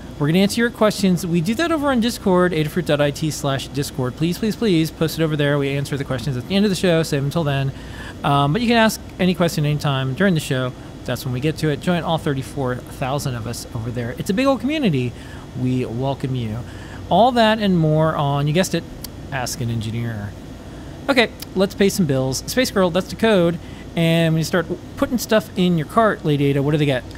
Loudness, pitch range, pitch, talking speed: -20 LUFS, 130-185 Hz, 150 Hz, 230 wpm